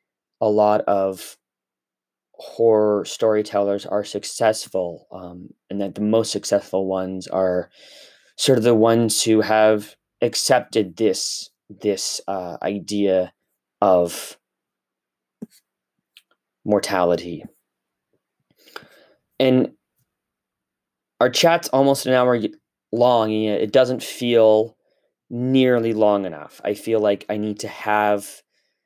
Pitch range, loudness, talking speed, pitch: 100-115 Hz, -20 LUFS, 100 wpm, 105 Hz